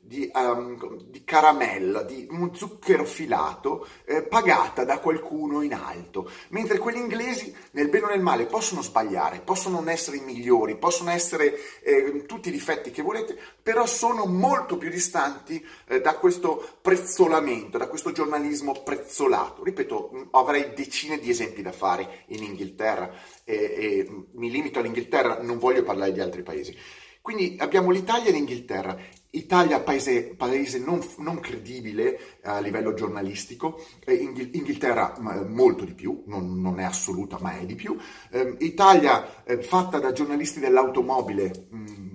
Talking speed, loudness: 150 wpm, -25 LUFS